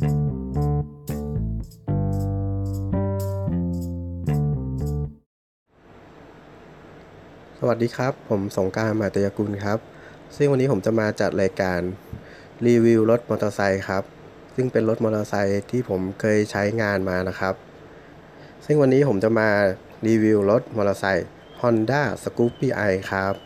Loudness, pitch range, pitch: -23 LUFS, 95-115 Hz, 100 Hz